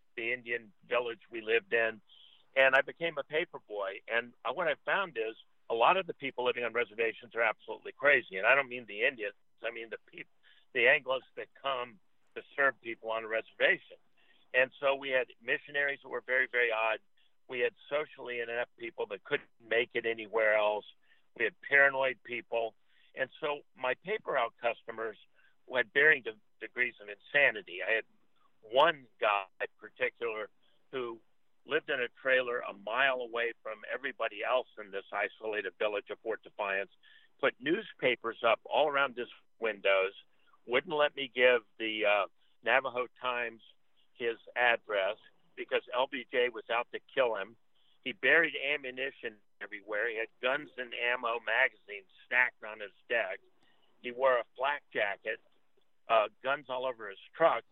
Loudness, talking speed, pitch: -32 LUFS, 165 wpm, 130 Hz